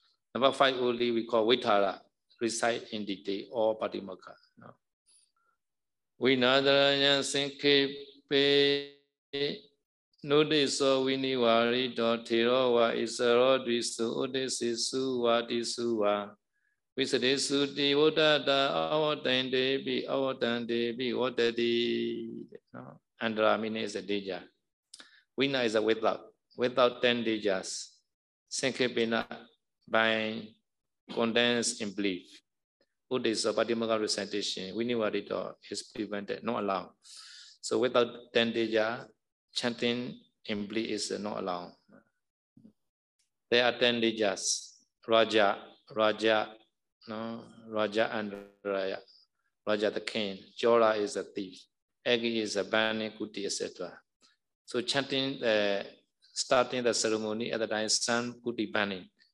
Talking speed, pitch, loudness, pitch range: 120 wpm, 120 Hz, -29 LUFS, 110-130 Hz